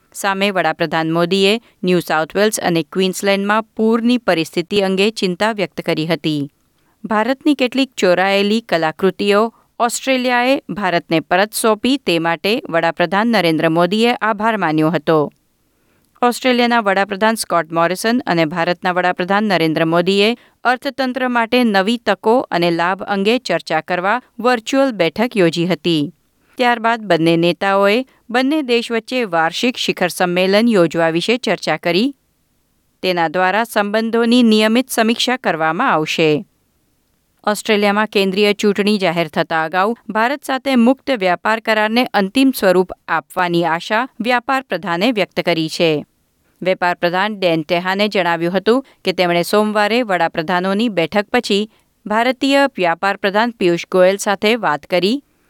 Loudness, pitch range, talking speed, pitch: -16 LUFS, 170-230 Hz, 120 wpm, 195 Hz